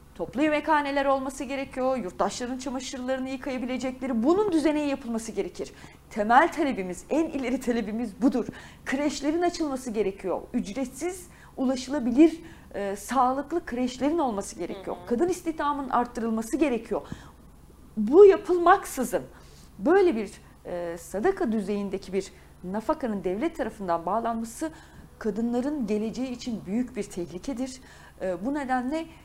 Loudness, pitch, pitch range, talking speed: -27 LUFS, 255 Hz, 215-290 Hz, 105 wpm